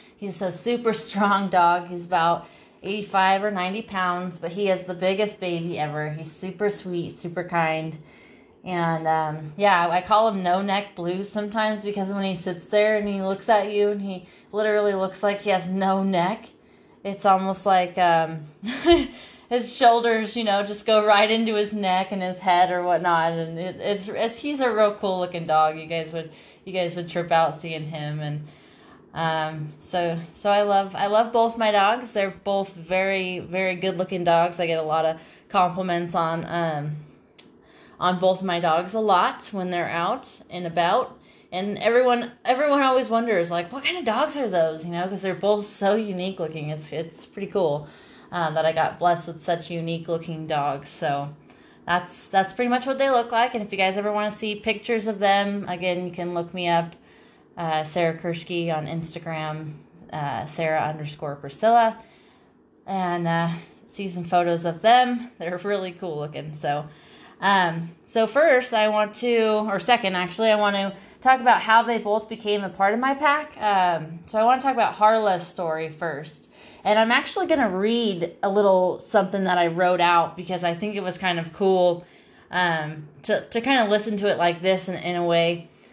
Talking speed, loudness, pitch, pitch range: 190 wpm, -23 LUFS, 185 Hz, 170-210 Hz